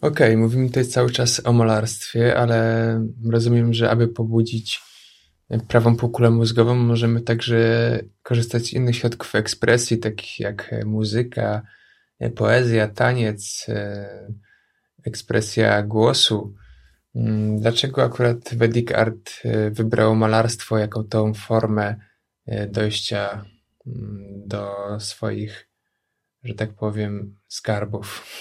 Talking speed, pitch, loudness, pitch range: 95 wpm, 115 Hz, -20 LUFS, 105-115 Hz